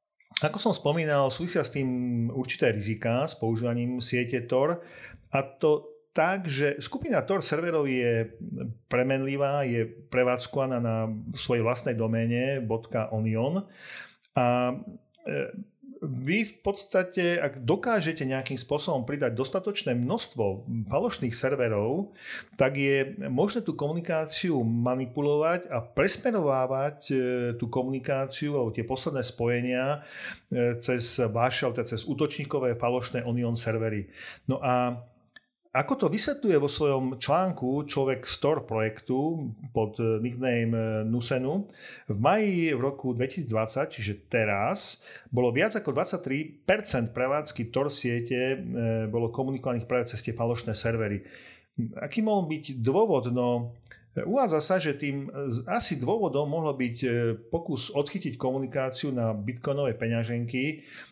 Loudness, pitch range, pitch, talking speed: -28 LUFS, 120-150 Hz, 130 Hz, 115 wpm